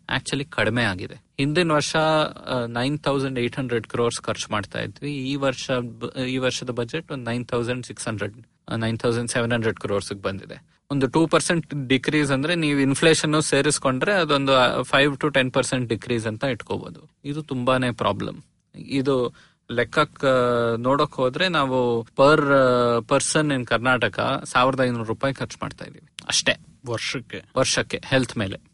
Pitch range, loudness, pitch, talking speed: 120-145 Hz, -22 LUFS, 130 Hz, 125 wpm